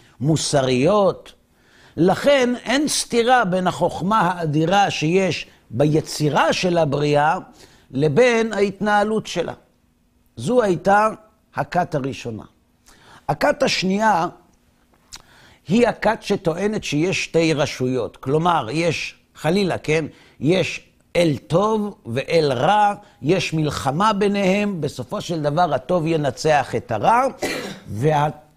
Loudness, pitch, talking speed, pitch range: -20 LUFS, 165 Hz, 95 wpm, 145-200 Hz